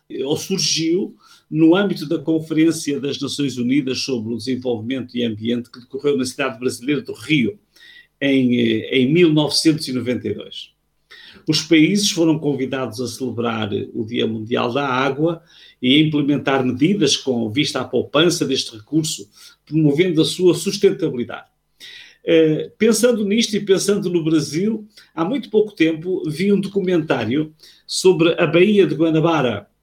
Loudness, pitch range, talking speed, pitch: -18 LUFS, 130-180 Hz, 135 wpm, 155 Hz